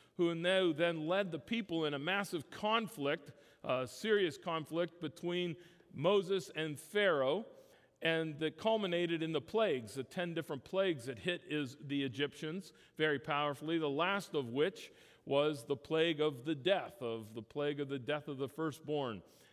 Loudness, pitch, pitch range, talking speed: -37 LUFS, 160 Hz, 145-175 Hz, 165 wpm